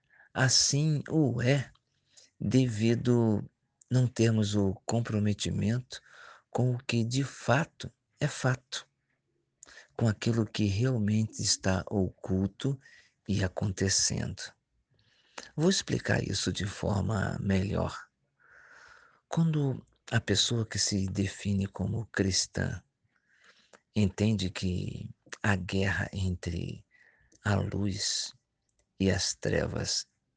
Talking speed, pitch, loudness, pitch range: 95 wpm, 110 Hz, -30 LUFS, 100-125 Hz